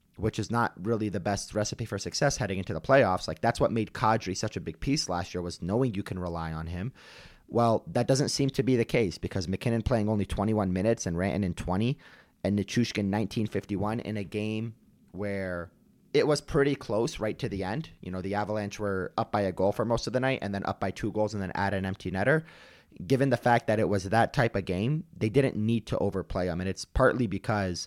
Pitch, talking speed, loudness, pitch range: 105 Hz, 235 wpm, -29 LUFS, 95-115 Hz